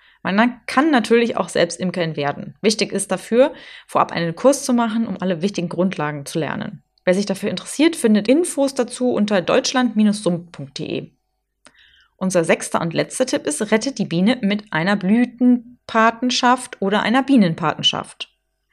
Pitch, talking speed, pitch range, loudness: 215 Hz, 145 wpm, 185-245 Hz, -19 LUFS